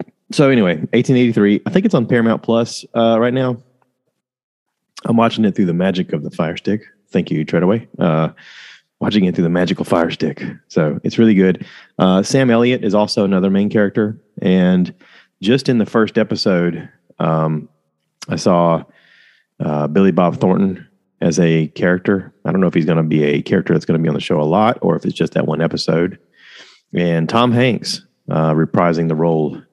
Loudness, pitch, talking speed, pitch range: -16 LUFS, 95 Hz, 190 wpm, 85-115 Hz